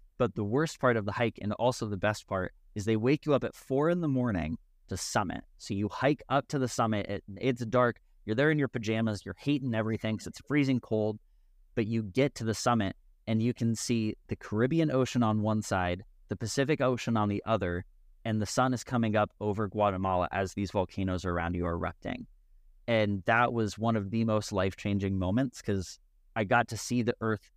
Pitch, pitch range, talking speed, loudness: 110 Hz, 100-125 Hz, 220 wpm, -30 LUFS